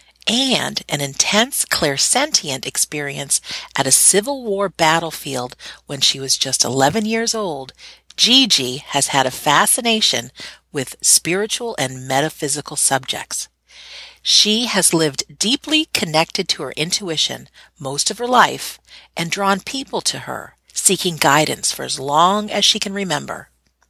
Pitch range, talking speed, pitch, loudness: 140-215 Hz, 135 wpm, 175 Hz, -16 LUFS